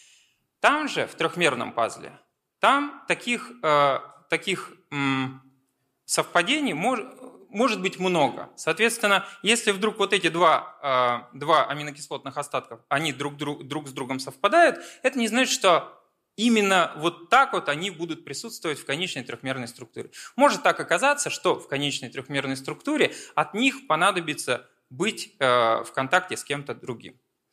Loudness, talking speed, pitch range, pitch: -24 LUFS, 135 wpm, 135-215 Hz, 165 Hz